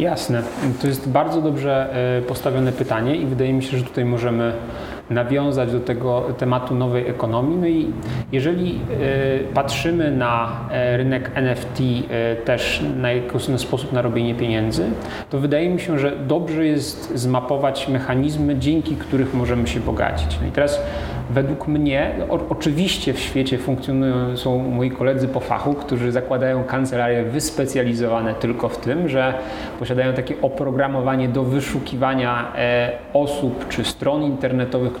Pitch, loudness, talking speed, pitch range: 130 Hz, -21 LUFS, 135 wpm, 120-140 Hz